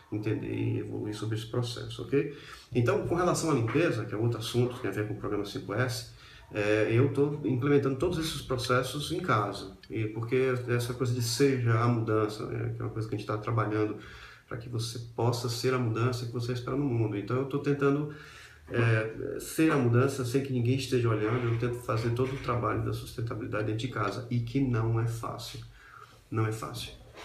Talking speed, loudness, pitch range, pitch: 210 wpm, -30 LUFS, 110-130 Hz, 120 Hz